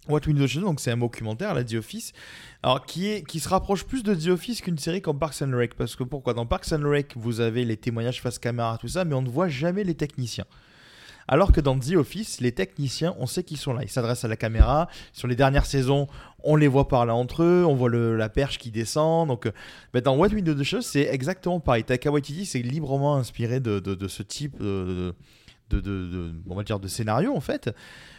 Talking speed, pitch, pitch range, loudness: 235 wpm, 135 Hz, 115-155 Hz, -25 LUFS